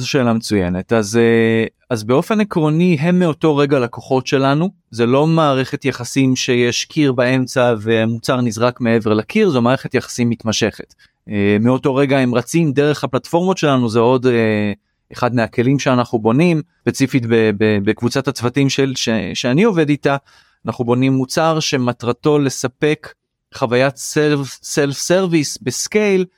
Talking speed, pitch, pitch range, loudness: 130 wpm, 130 Hz, 115-145 Hz, -16 LUFS